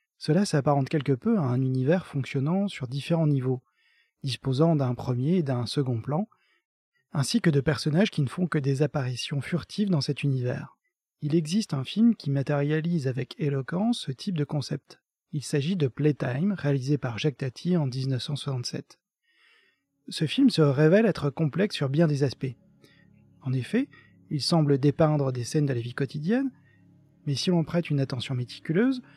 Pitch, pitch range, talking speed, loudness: 150 Hz, 135-175 Hz, 170 wpm, -27 LUFS